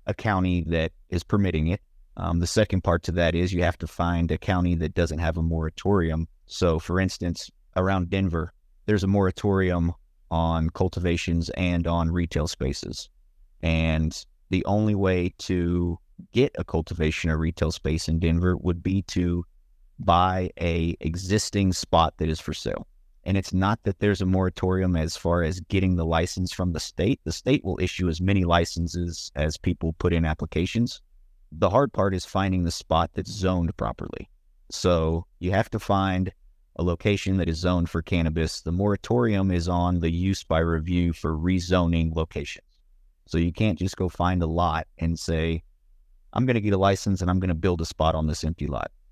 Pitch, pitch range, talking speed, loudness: 85 Hz, 80-95 Hz, 185 wpm, -25 LUFS